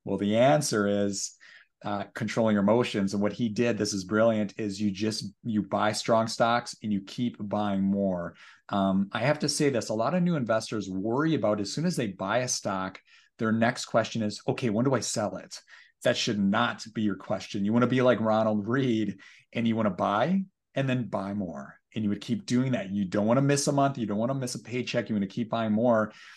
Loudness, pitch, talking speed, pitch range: -28 LUFS, 110 Hz, 240 wpm, 105-120 Hz